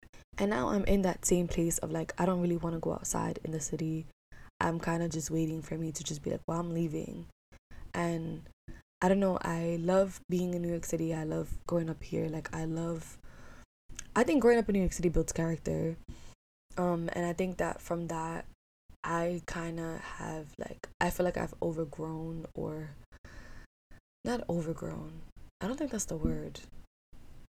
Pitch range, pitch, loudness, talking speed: 160-180 Hz, 165 Hz, -33 LUFS, 190 wpm